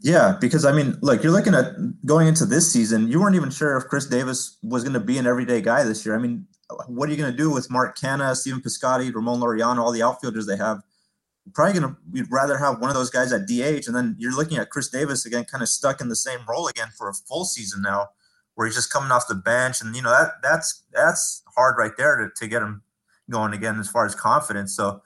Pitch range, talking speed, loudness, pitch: 115-150 Hz, 255 wpm, -22 LUFS, 130 Hz